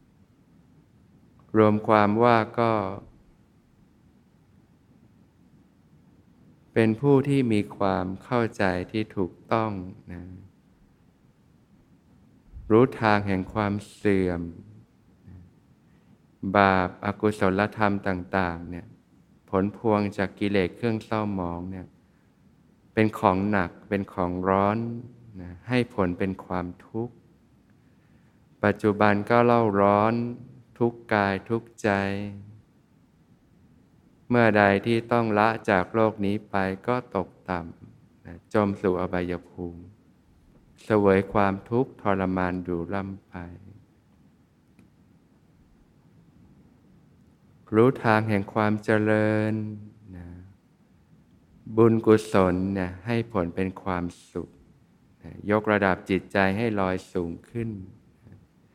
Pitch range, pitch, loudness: 95-110 Hz, 100 Hz, -25 LUFS